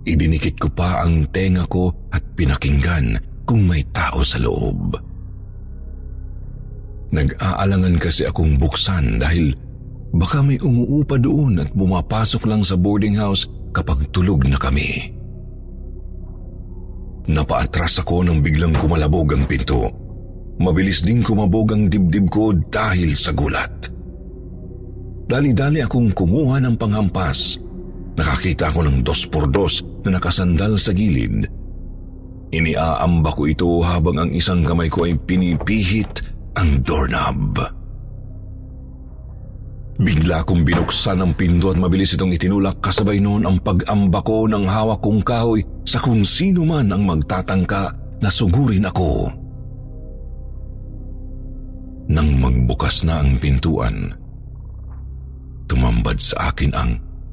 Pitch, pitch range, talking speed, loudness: 90 Hz, 80-100 Hz, 115 wpm, -18 LUFS